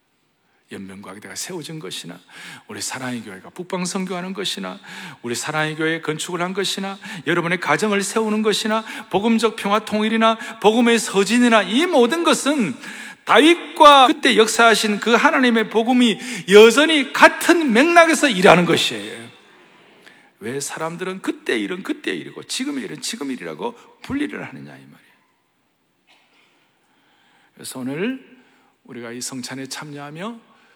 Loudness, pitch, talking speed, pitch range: -17 LUFS, 215 Hz, 315 characters per minute, 180-255 Hz